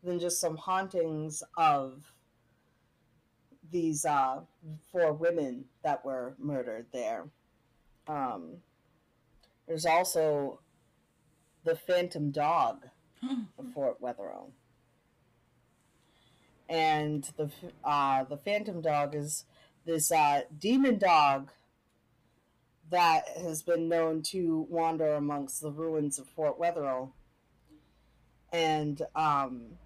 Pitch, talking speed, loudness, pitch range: 155 Hz, 95 wpm, -31 LUFS, 140-170 Hz